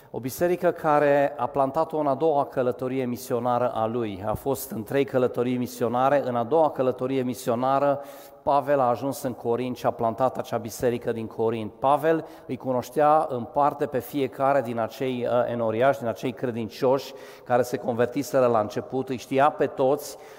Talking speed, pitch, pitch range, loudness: 170 wpm, 130 Hz, 120-140 Hz, -25 LUFS